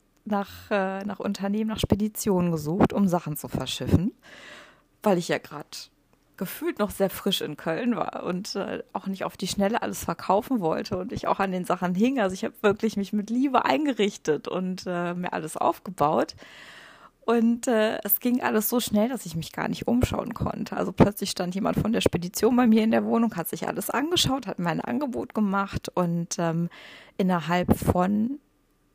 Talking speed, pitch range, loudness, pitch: 185 wpm, 180-220 Hz, -26 LUFS, 200 Hz